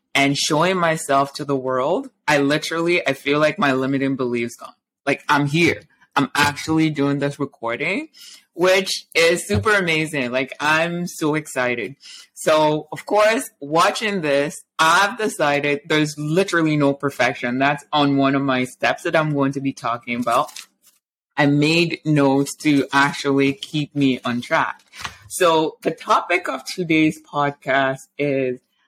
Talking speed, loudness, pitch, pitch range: 150 wpm, -19 LUFS, 145 Hz, 140-160 Hz